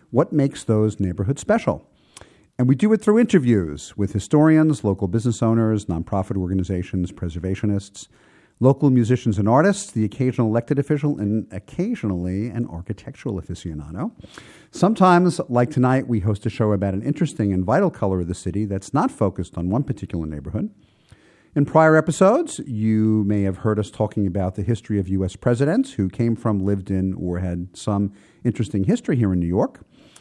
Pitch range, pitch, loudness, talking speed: 95-135 Hz, 110 Hz, -21 LUFS, 165 wpm